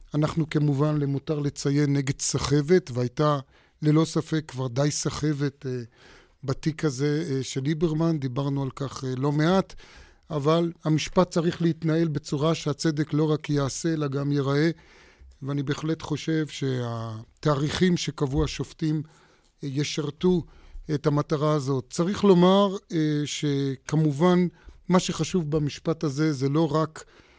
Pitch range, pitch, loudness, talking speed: 140-160 Hz, 150 Hz, -25 LUFS, 115 wpm